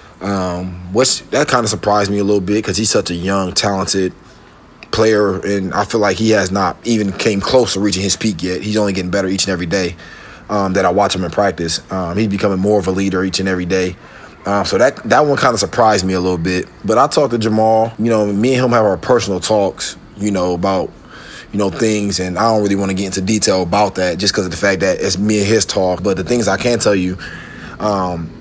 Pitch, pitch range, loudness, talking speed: 100 Hz, 95-110 Hz, -15 LUFS, 260 wpm